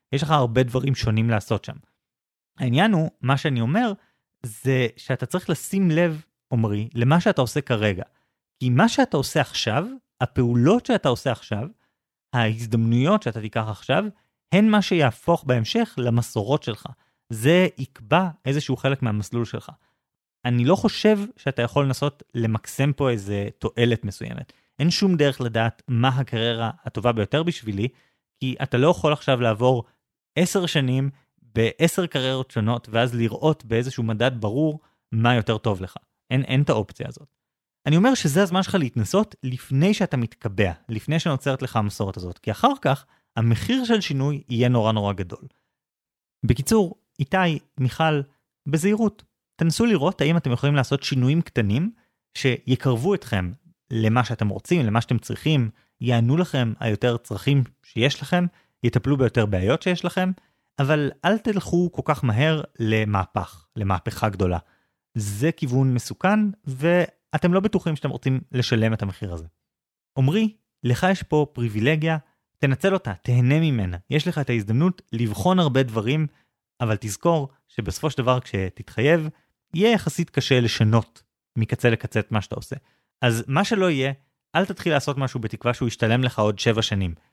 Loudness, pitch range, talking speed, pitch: -23 LUFS, 115-160 Hz, 150 wpm, 130 Hz